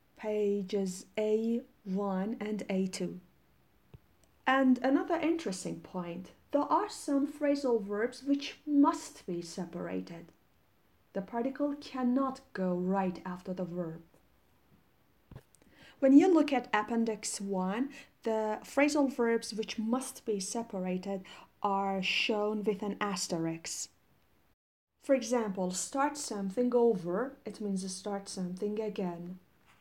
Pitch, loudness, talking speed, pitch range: 215 Hz, -33 LUFS, 105 wpm, 190-260 Hz